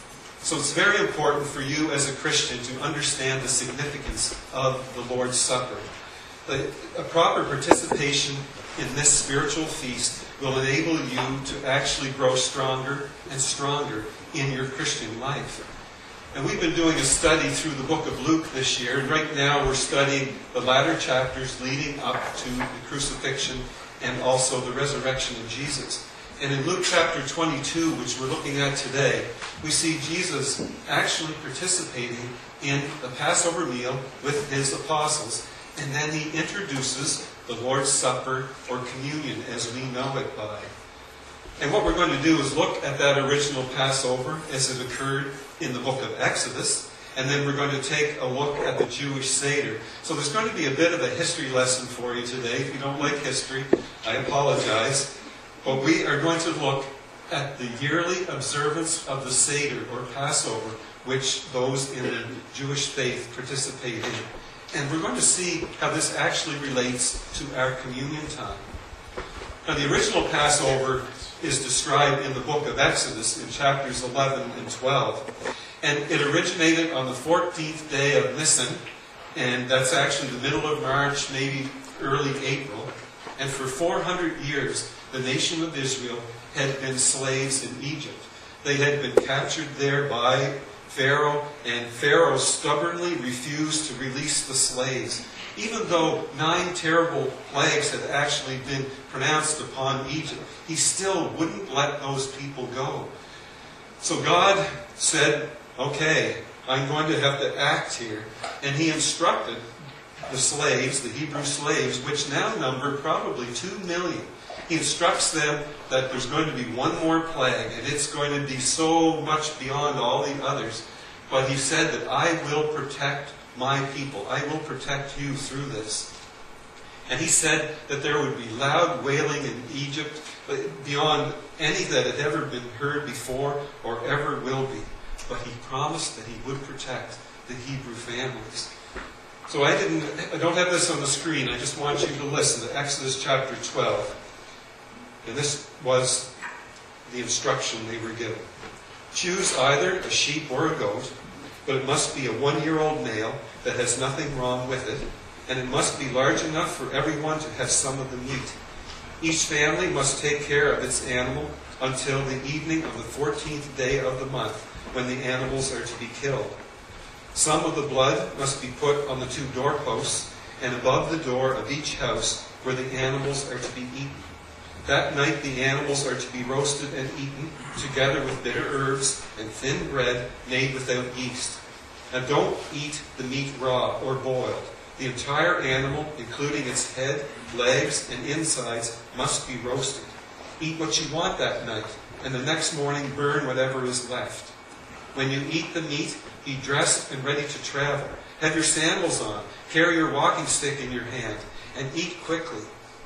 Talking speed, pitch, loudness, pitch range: 165 wpm, 140 Hz, -25 LUFS, 130-150 Hz